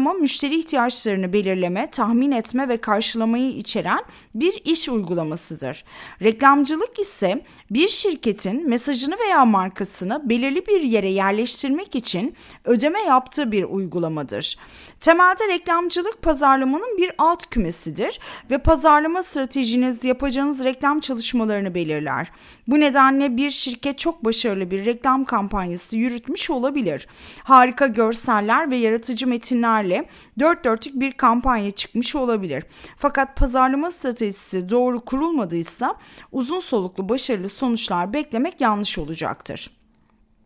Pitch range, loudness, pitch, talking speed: 215-285 Hz, -19 LUFS, 255 Hz, 110 wpm